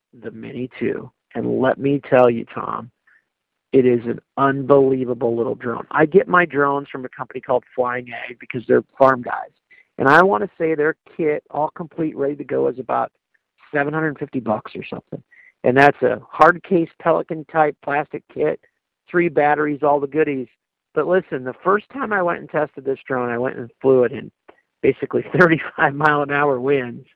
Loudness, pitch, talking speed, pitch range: -19 LUFS, 140 Hz, 195 wpm, 130-160 Hz